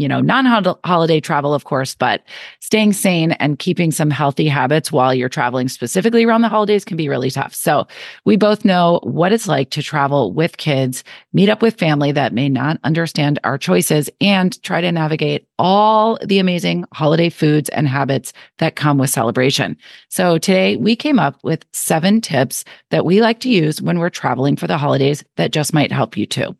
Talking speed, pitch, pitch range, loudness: 195 wpm, 155 Hz, 140-190 Hz, -16 LUFS